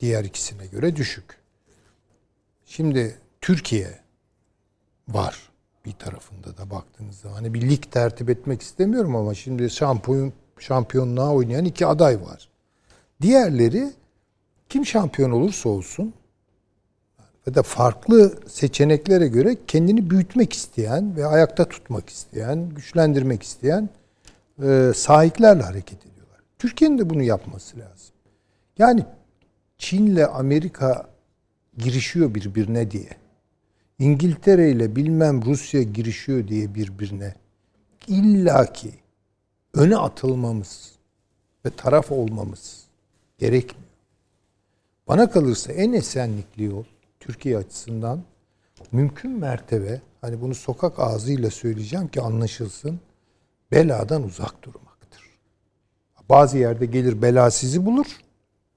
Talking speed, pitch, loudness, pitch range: 100 wpm, 120 Hz, -20 LUFS, 105-145 Hz